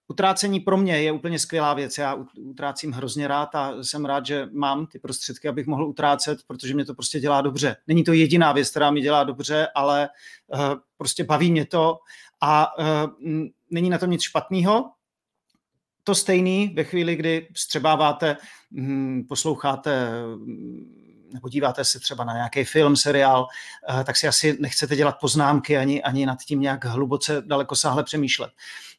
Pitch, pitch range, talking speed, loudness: 145 Hz, 140-155 Hz, 155 wpm, -22 LUFS